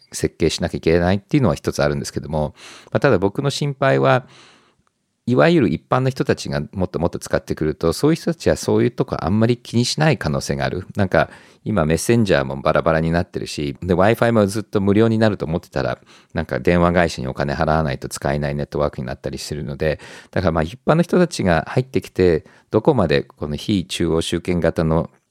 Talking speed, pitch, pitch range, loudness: 460 characters per minute, 85 Hz, 75-110 Hz, -19 LUFS